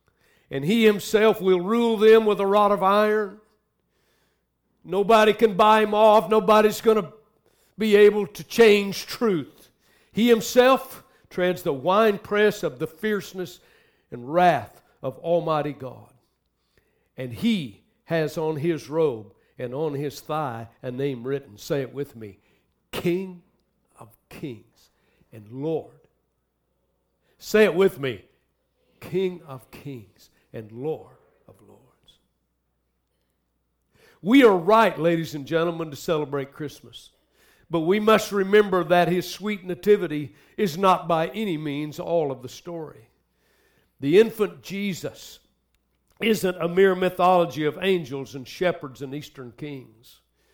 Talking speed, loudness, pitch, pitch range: 130 wpm, -22 LUFS, 175 Hz, 140-210 Hz